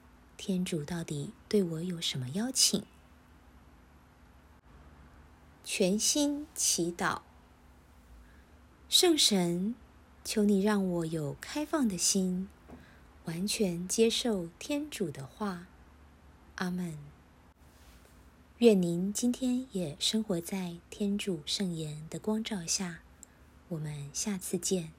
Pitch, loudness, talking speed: 170 Hz, -31 LUFS, 135 characters per minute